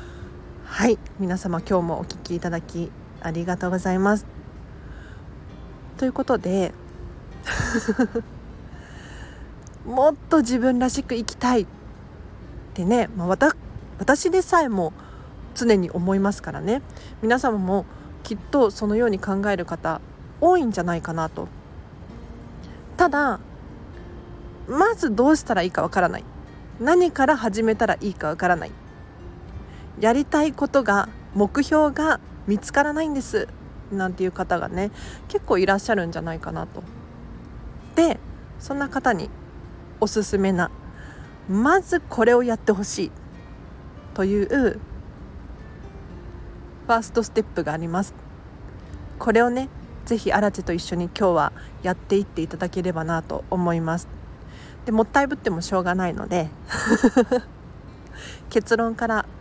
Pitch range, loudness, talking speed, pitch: 180-250 Hz, -23 LUFS, 260 characters per minute, 205 Hz